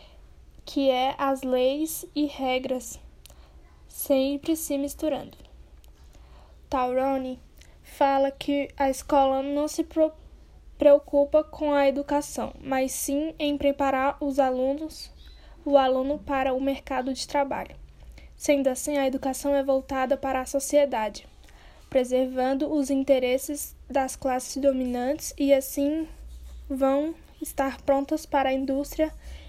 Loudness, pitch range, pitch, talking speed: -26 LUFS, 260-290 Hz, 275 Hz, 115 wpm